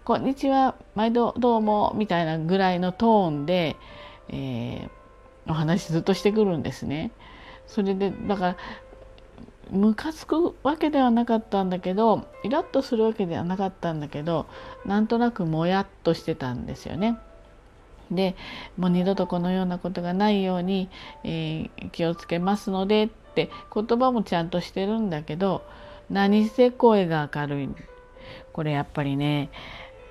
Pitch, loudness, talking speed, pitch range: 195 Hz, -25 LUFS, 305 characters per minute, 170-225 Hz